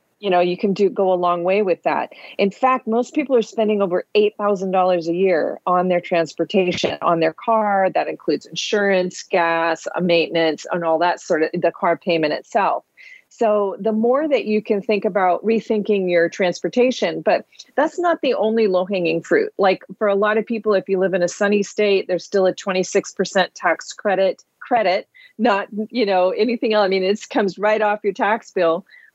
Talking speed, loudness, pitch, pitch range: 190 wpm, -19 LUFS, 195 Hz, 180-215 Hz